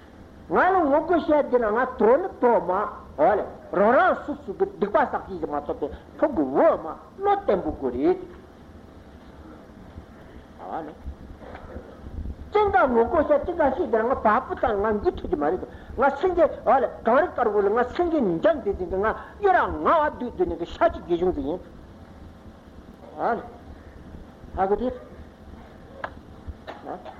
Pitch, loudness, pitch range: 285 Hz, -23 LUFS, 215-340 Hz